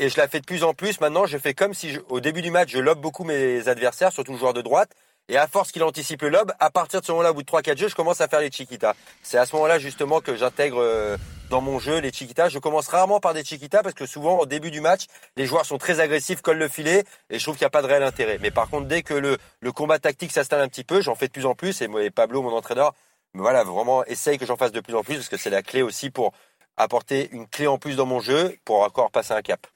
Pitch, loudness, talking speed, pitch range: 145 Hz, -23 LUFS, 300 wpm, 130-165 Hz